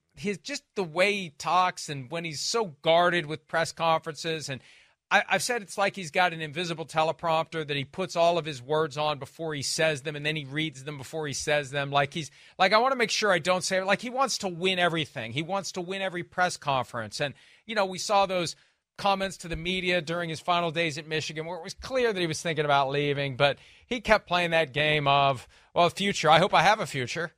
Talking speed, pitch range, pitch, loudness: 245 wpm, 150-185 Hz, 165 Hz, -27 LUFS